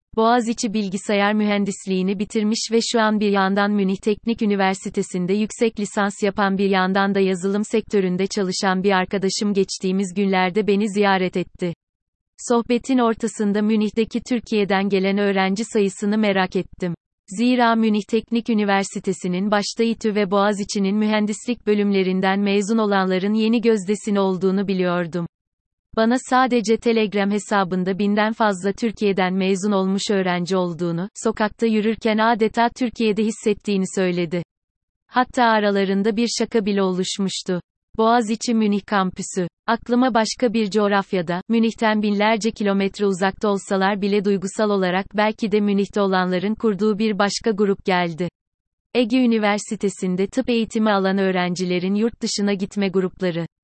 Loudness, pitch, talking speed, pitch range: -20 LUFS, 205 Hz, 125 wpm, 190-220 Hz